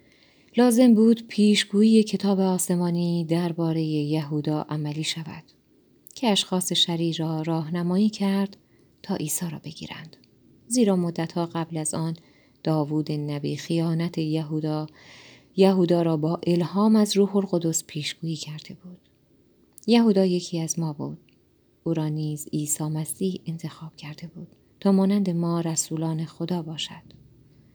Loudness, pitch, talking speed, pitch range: -24 LUFS, 165 Hz, 125 wpm, 155-190 Hz